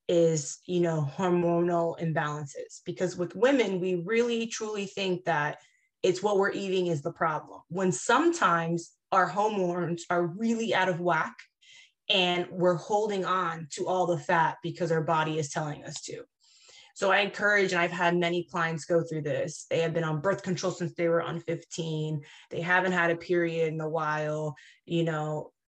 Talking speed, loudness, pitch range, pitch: 175 wpm, -28 LUFS, 165-190 Hz, 175 Hz